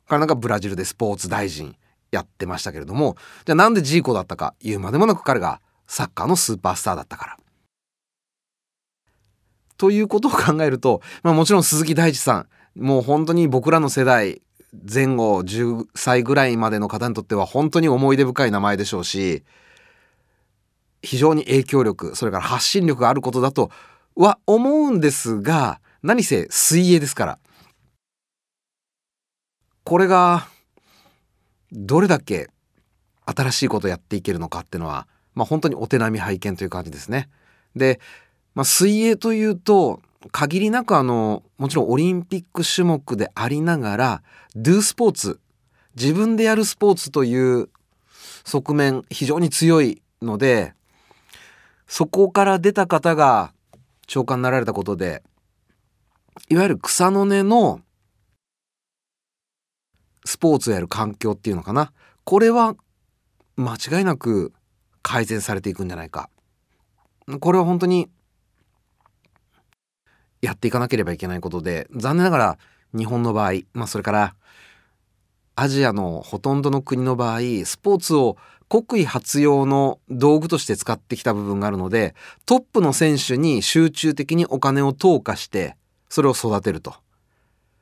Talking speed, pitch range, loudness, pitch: 295 characters per minute, 105-160 Hz, -19 LUFS, 130 Hz